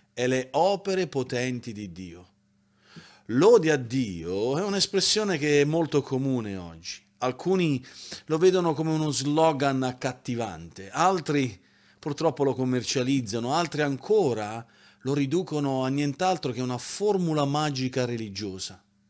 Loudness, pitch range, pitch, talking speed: -26 LUFS, 115-160 Hz, 135 Hz, 120 wpm